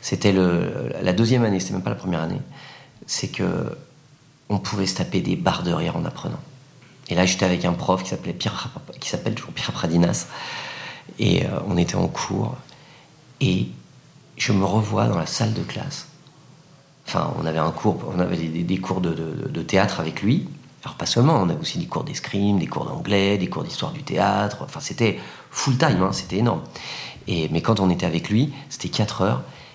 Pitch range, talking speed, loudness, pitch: 90-140 Hz, 200 wpm, -23 LUFS, 100 Hz